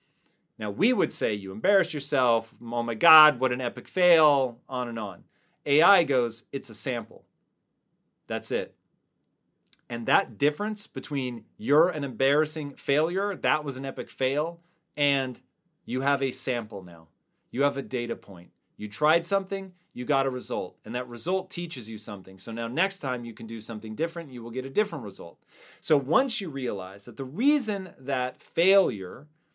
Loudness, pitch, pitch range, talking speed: -26 LUFS, 135 Hz, 120-165 Hz, 175 wpm